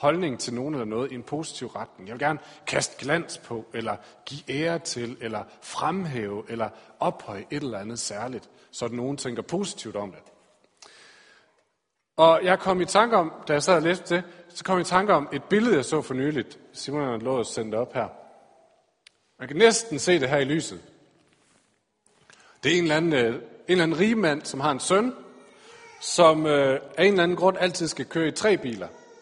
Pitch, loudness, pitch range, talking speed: 150 Hz, -25 LUFS, 125-180 Hz, 200 wpm